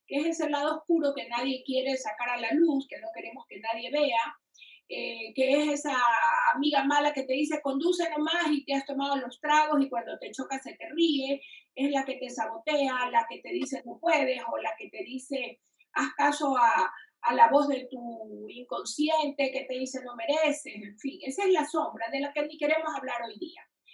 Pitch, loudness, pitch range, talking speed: 285 Hz, -28 LUFS, 260-310 Hz, 215 wpm